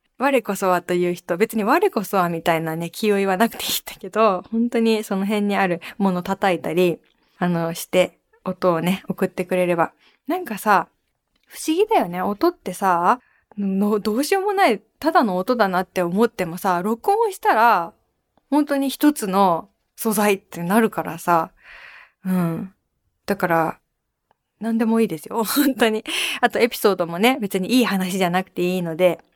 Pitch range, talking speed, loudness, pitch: 180-235 Hz, 325 characters per minute, -21 LUFS, 200 Hz